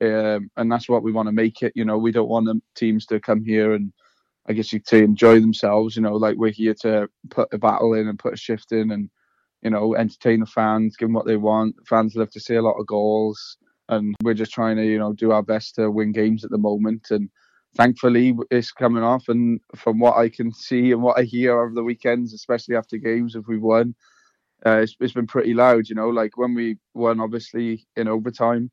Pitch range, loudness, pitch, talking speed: 110-115 Hz, -20 LUFS, 110 Hz, 240 wpm